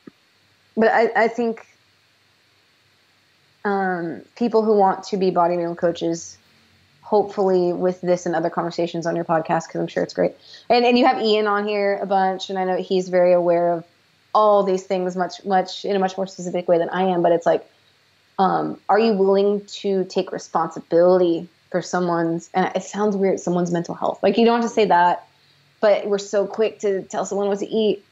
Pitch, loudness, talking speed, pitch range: 185 Hz, -20 LUFS, 195 wpm, 170-200 Hz